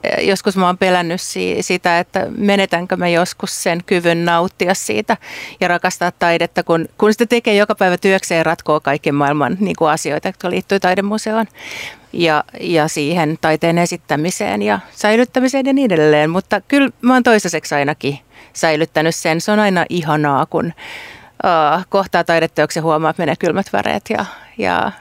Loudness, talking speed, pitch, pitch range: -16 LUFS, 160 wpm, 175 Hz, 160-195 Hz